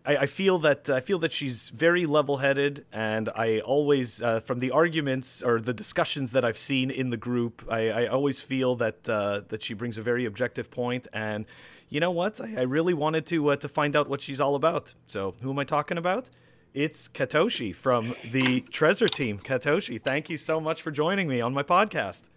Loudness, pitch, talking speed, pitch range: -27 LUFS, 135 Hz, 210 wpm, 120-150 Hz